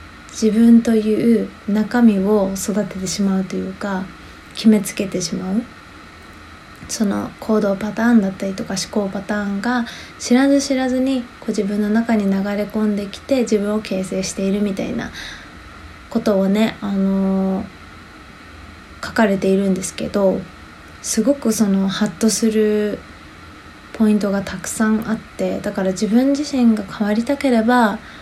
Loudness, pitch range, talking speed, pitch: -18 LUFS, 195-225 Hz, 290 characters per minute, 210 Hz